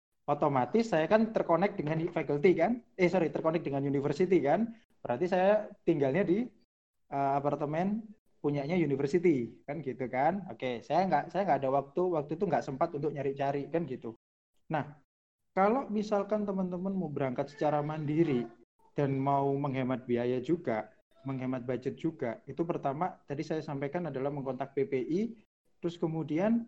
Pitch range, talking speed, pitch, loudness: 140-180 Hz, 150 wpm, 150 Hz, -32 LUFS